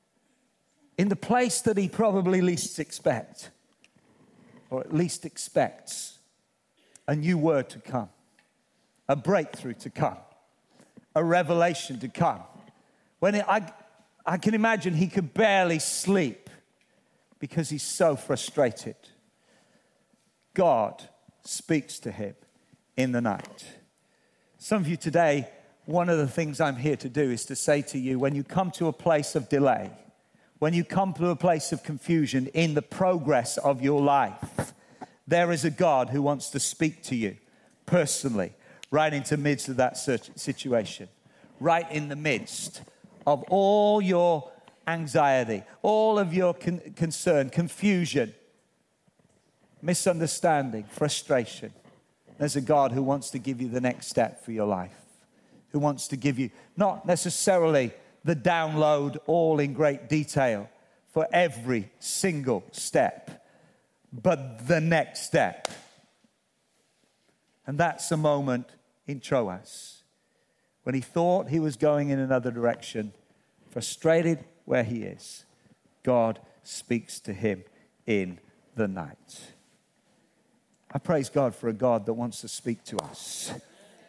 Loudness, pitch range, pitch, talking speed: -27 LUFS, 135-175 Hz, 155 Hz, 135 wpm